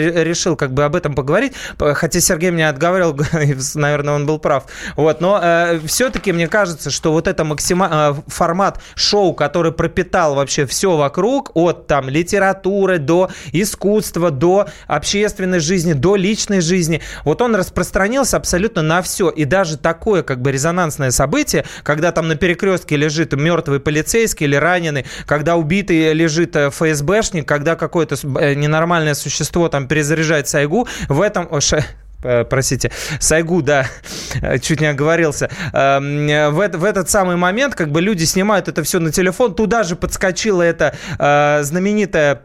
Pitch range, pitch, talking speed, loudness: 150-185 Hz, 165 Hz, 150 wpm, -16 LUFS